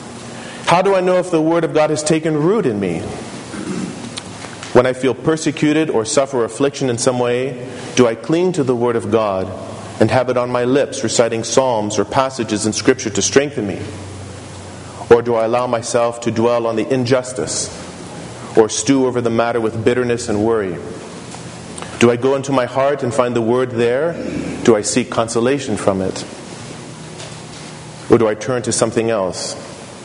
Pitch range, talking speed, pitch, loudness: 110-130 Hz, 180 wpm, 120 Hz, -17 LUFS